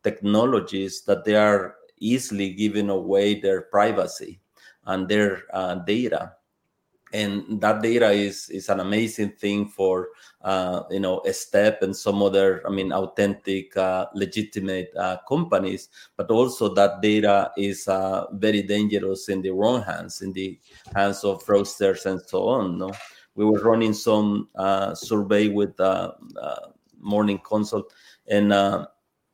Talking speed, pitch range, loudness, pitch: 145 wpm, 95-105 Hz, -23 LUFS, 100 Hz